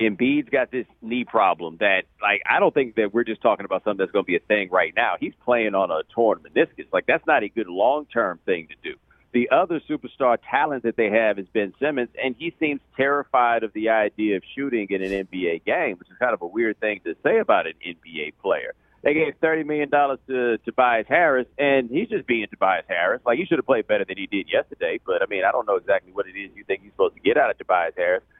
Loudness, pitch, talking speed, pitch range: -22 LUFS, 125 Hz, 250 wpm, 110-160 Hz